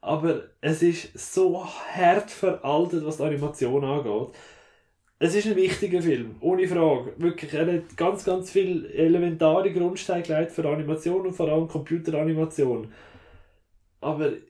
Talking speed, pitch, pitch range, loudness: 130 wpm, 165 Hz, 150-185 Hz, -25 LUFS